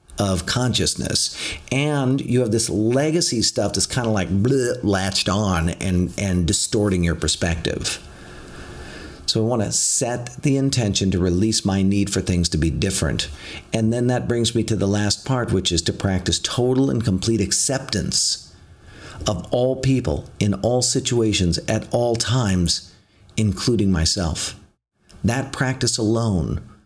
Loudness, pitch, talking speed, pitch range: -20 LUFS, 105 Hz, 150 wpm, 90-120 Hz